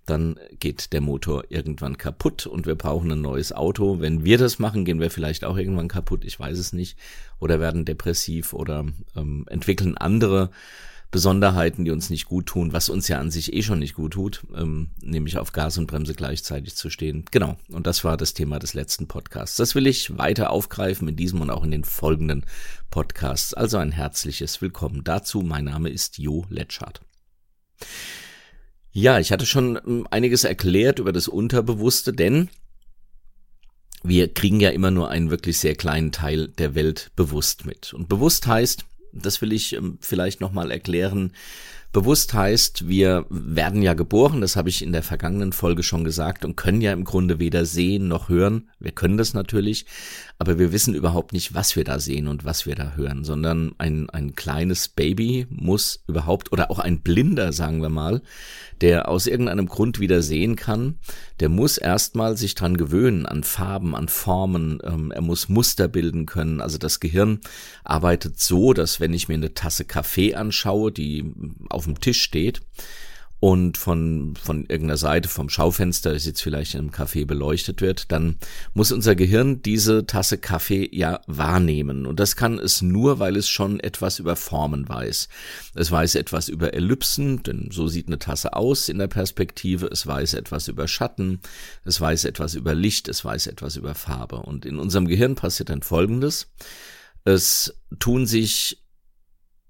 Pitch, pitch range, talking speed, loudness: 85 Hz, 80-100 Hz, 180 wpm, -22 LUFS